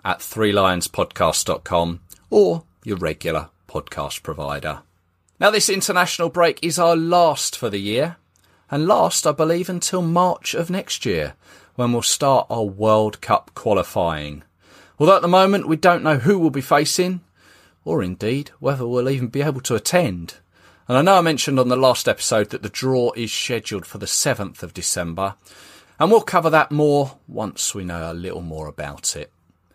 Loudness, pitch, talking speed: -19 LUFS, 125 Hz, 170 wpm